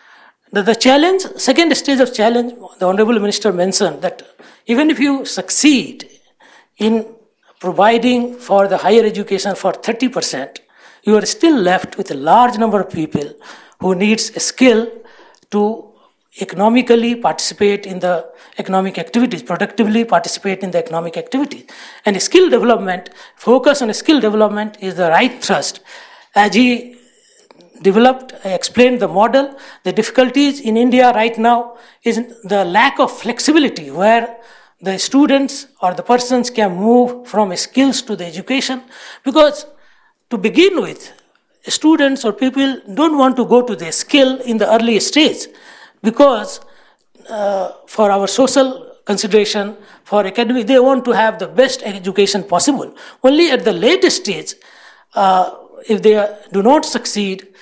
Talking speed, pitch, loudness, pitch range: 145 wpm, 225 Hz, -14 LUFS, 200-260 Hz